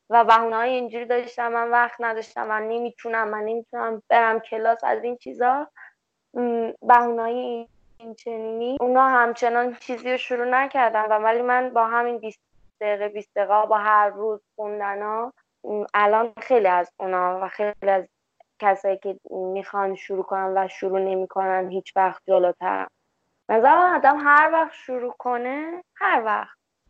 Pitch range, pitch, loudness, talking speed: 205-245 Hz, 225 Hz, -22 LUFS, 140 wpm